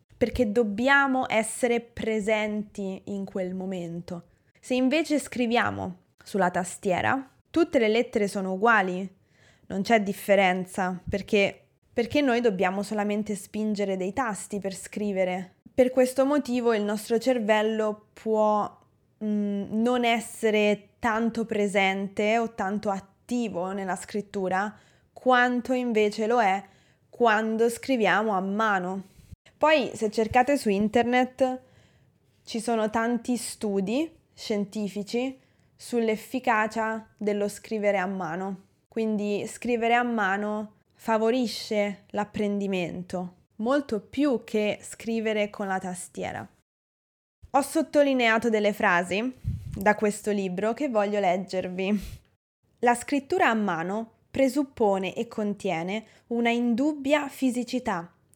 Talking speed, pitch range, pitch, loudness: 105 wpm, 200-240 Hz, 215 Hz, -26 LUFS